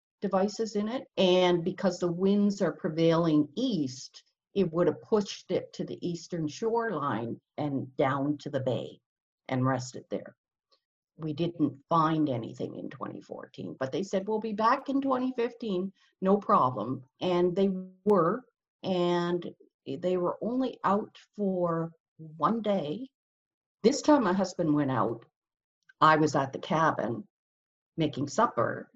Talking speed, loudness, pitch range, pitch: 140 wpm, -29 LUFS, 150-205 Hz, 180 Hz